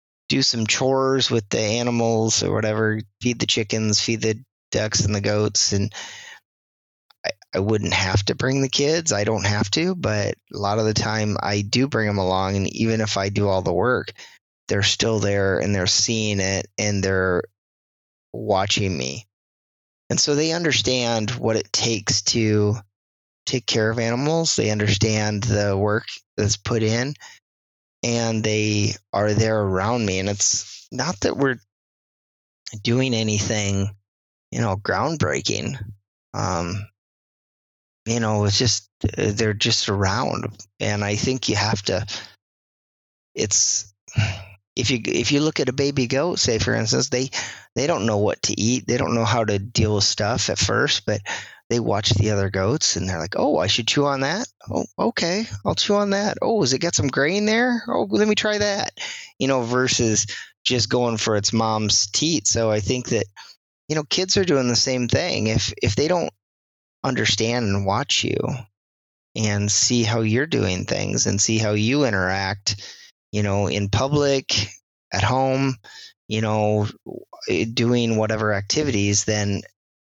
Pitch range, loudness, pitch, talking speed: 100-125 Hz, -21 LUFS, 110 Hz, 170 wpm